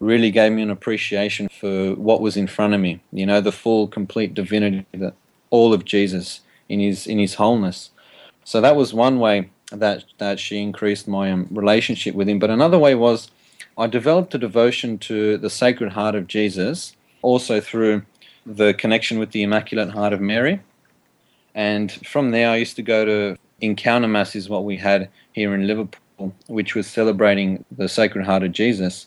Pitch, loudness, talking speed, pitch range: 105 Hz, -19 LUFS, 185 wpm, 100-110 Hz